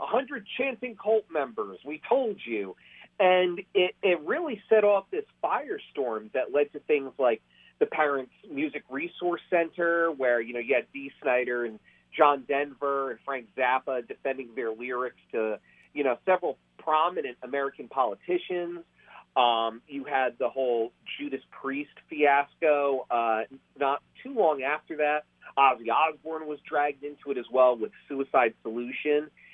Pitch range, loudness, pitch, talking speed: 130-180 Hz, -28 LUFS, 145 Hz, 150 wpm